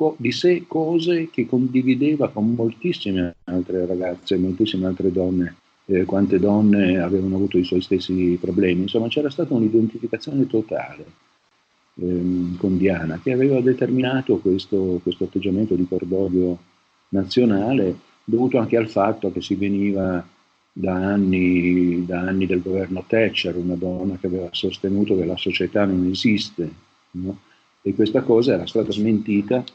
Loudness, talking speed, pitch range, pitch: -21 LUFS, 140 wpm, 90-115 Hz, 95 Hz